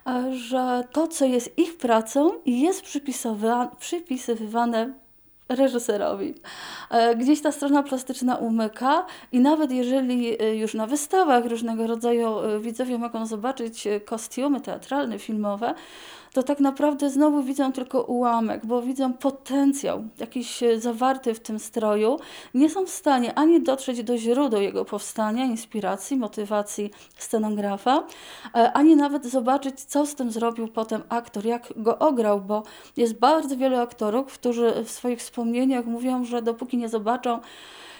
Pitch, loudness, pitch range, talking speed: 245 Hz, -24 LUFS, 230-270 Hz, 130 wpm